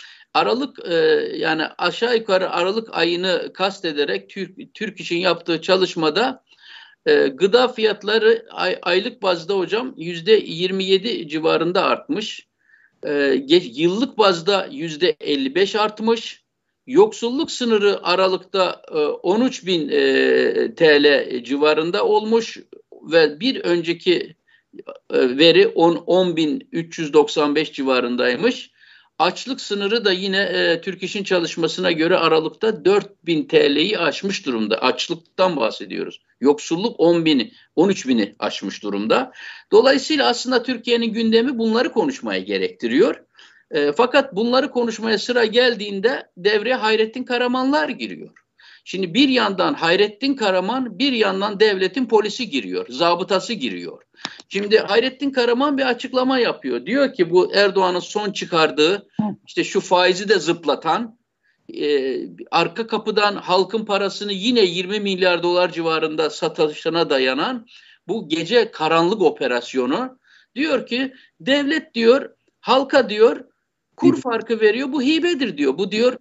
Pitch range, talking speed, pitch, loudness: 180-265 Hz, 115 wpm, 215 Hz, -19 LUFS